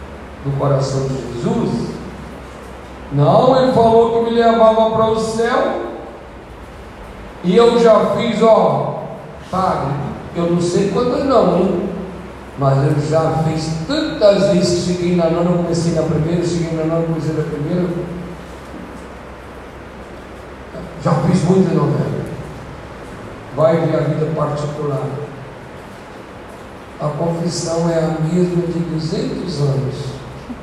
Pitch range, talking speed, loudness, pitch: 150-185 Hz, 120 wpm, -16 LUFS, 165 Hz